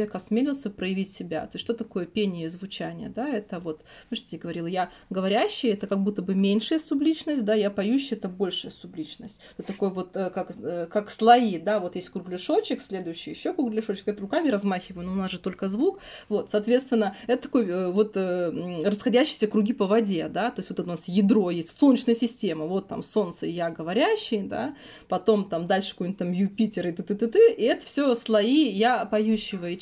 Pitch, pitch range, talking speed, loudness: 205 Hz, 185-230 Hz, 185 wpm, -26 LUFS